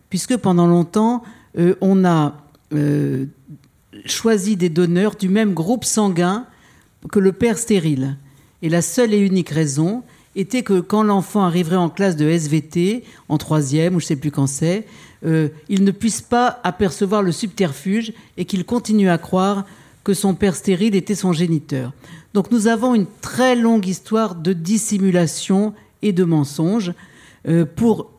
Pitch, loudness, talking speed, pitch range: 190 Hz, -18 LUFS, 160 wpm, 165-210 Hz